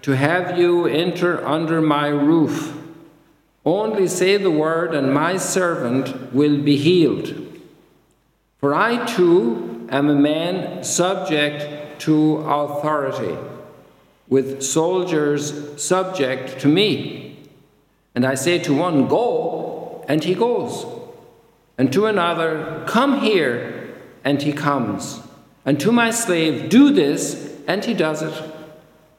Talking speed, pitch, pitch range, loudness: 120 wpm, 155 Hz, 145-175 Hz, -19 LUFS